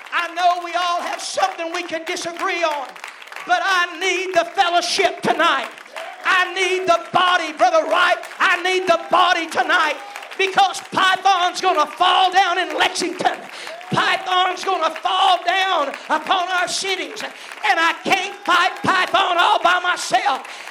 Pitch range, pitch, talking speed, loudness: 345-370 Hz, 360 Hz, 140 wpm, -18 LUFS